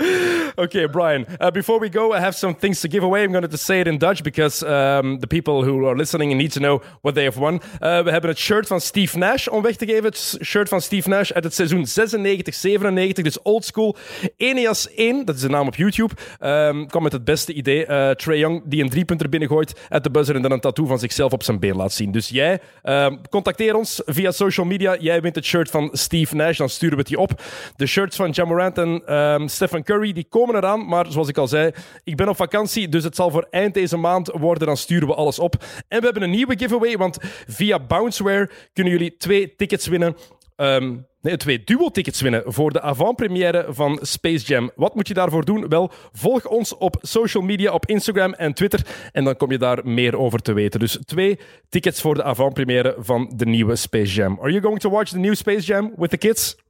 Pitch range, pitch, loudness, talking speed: 145-200 Hz, 170 Hz, -20 LUFS, 235 wpm